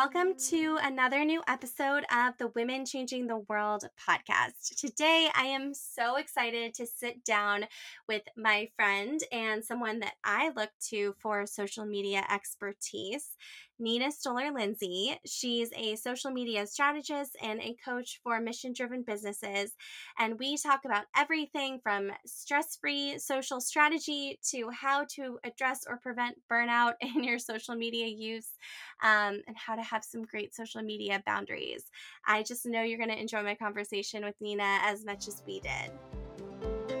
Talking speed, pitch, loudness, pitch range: 155 wpm, 235 Hz, -32 LUFS, 210-270 Hz